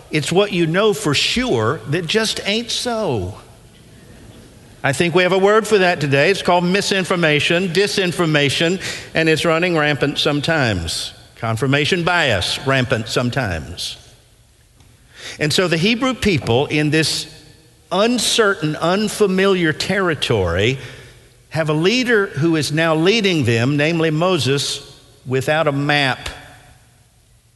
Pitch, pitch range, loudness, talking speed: 155 Hz, 130-185 Hz, -17 LUFS, 120 wpm